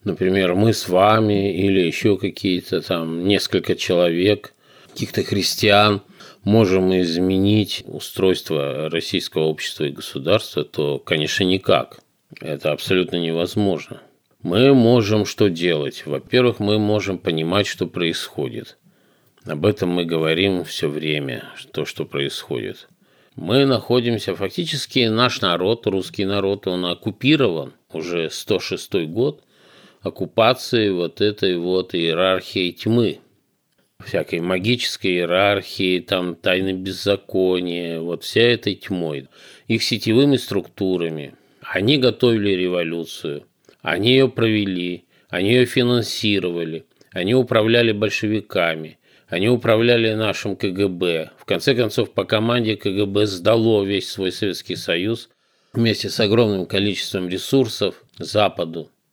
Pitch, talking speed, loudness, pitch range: 100 Hz, 110 wpm, -20 LUFS, 90-110 Hz